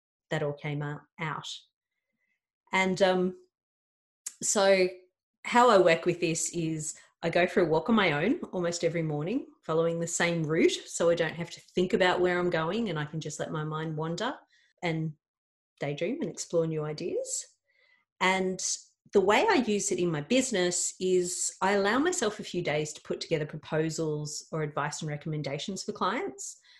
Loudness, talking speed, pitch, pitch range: -29 LUFS, 175 wpm, 175 Hz, 160-200 Hz